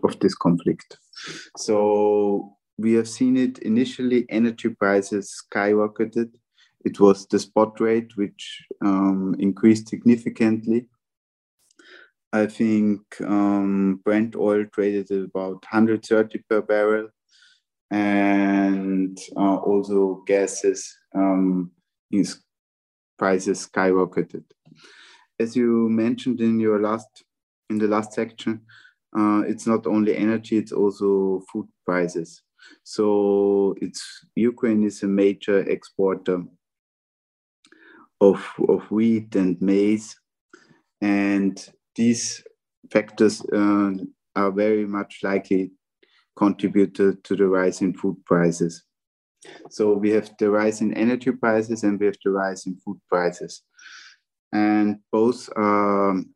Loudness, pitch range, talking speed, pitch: -22 LUFS, 95-110 Hz, 115 wpm, 105 Hz